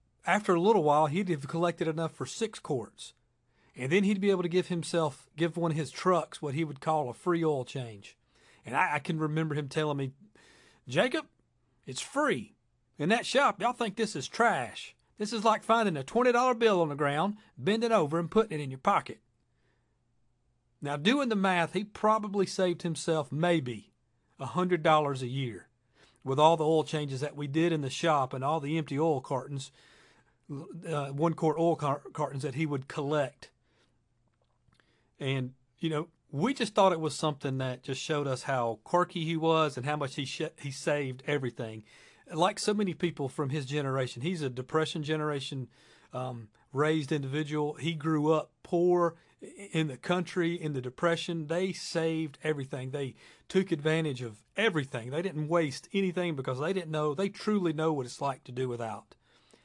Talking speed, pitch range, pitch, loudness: 185 wpm, 140-175 Hz, 155 Hz, -30 LUFS